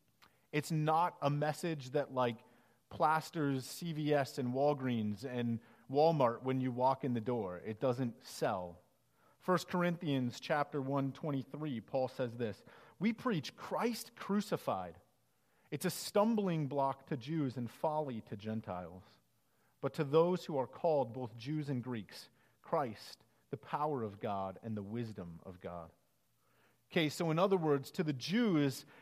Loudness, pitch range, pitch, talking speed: -37 LUFS, 120-160 Hz, 140 Hz, 145 wpm